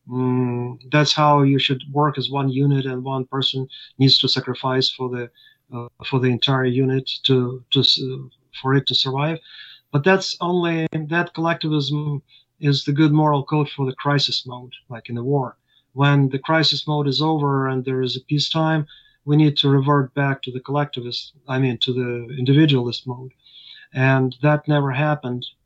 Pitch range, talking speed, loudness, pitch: 130-150 Hz, 175 wpm, -20 LUFS, 135 Hz